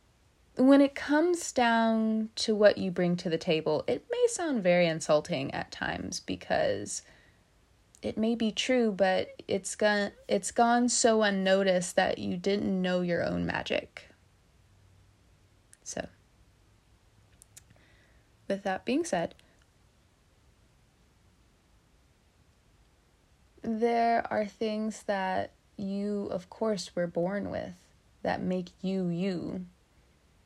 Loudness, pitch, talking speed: -29 LUFS, 185 Hz, 110 wpm